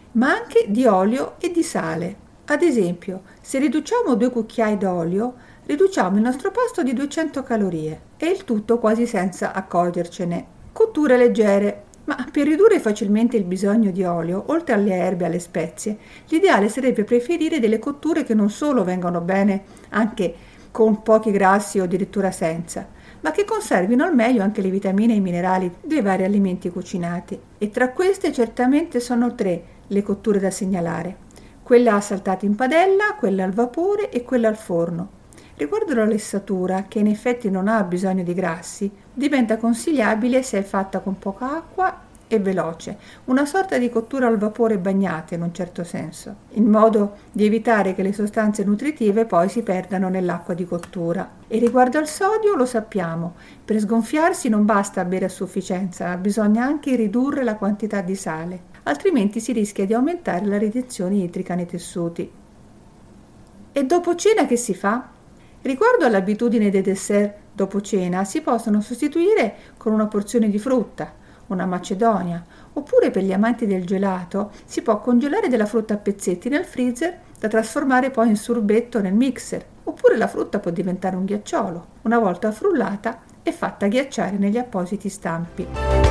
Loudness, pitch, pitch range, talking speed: -21 LUFS, 215 Hz, 190-250 Hz, 160 wpm